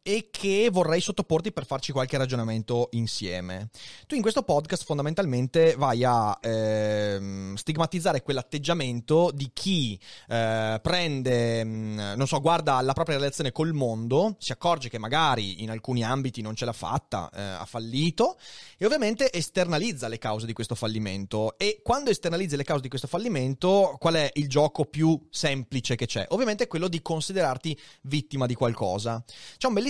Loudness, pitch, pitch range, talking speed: -27 LUFS, 135 Hz, 115-165 Hz, 165 wpm